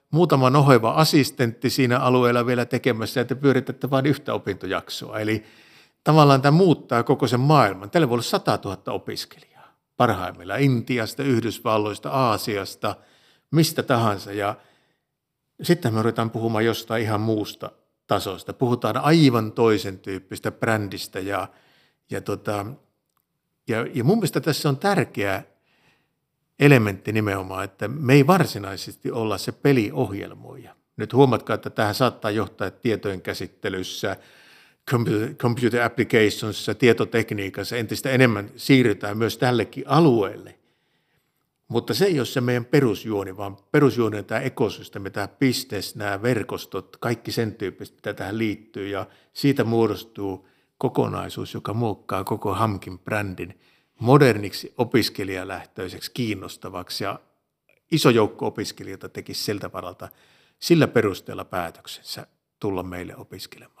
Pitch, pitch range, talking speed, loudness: 115 Hz, 105-130 Hz, 120 wpm, -22 LUFS